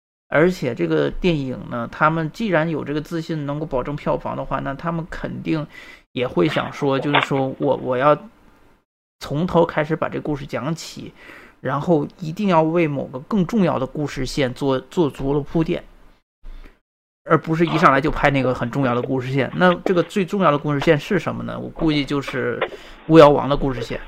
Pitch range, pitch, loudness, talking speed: 135-165 Hz, 150 Hz, -20 LUFS, 280 characters per minute